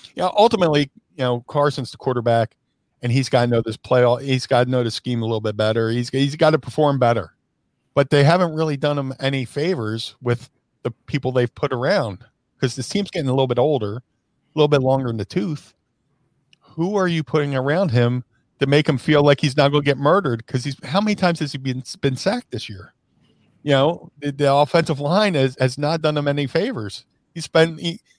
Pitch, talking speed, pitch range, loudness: 135 Hz, 225 wpm, 125-150 Hz, -20 LUFS